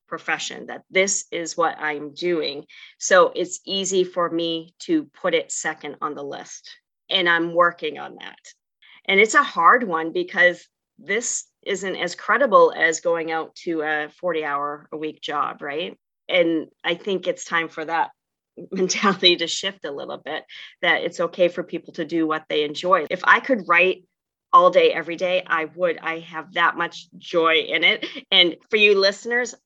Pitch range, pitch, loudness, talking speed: 165-200 Hz, 175 Hz, -21 LUFS, 180 wpm